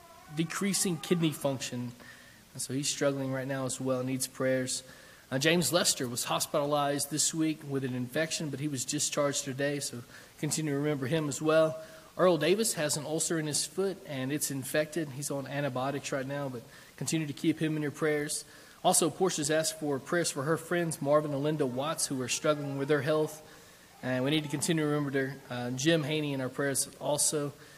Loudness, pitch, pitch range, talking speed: -31 LUFS, 150 Hz, 135-160 Hz, 200 wpm